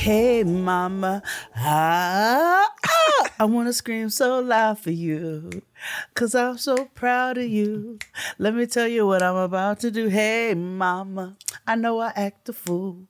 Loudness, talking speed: -22 LUFS, 155 wpm